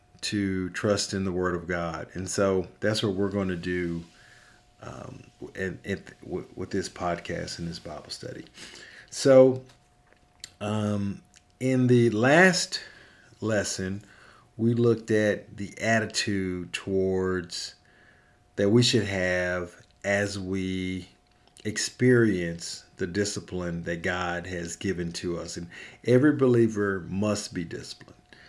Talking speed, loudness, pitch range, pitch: 125 wpm, -26 LUFS, 90-110 Hz, 100 Hz